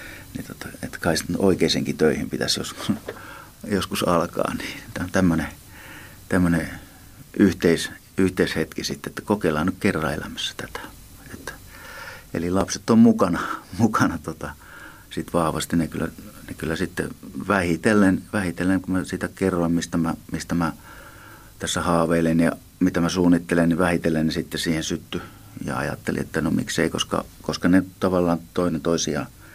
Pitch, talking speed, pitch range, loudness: 90 Hz, 145 wpm, 85-95 Hz, -23 LUFS